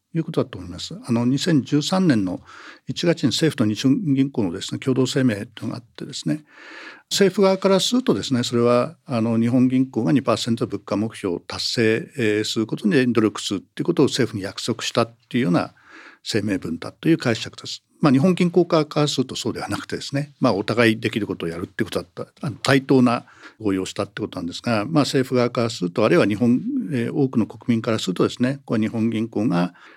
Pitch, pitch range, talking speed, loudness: 125 Hz, 110-145 Hz, 410 characters per minute, -21 LUFS